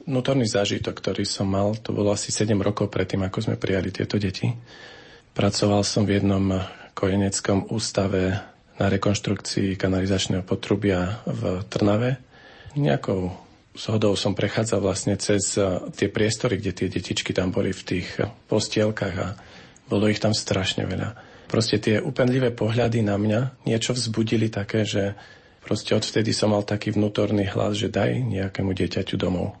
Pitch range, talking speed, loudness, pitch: 95-110 Hz, 145 wpm, -24 LUFS, 100 Hz